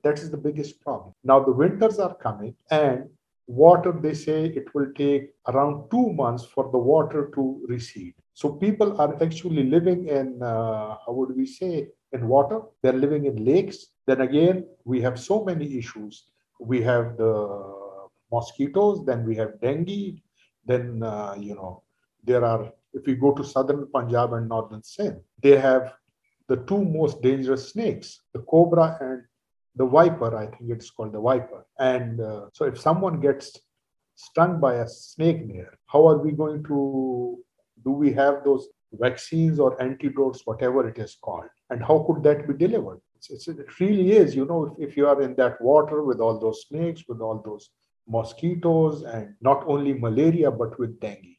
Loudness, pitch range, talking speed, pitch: -23 LUFS, 120-155 Hz, 175 wpm, 135 Hz